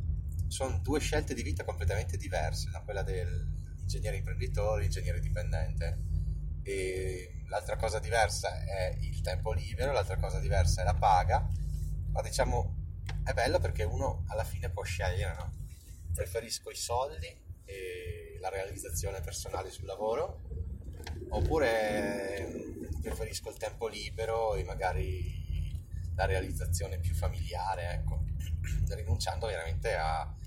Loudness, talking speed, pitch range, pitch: -34 LUFS, 125 wpm, 80-95 Hz, 85 Hz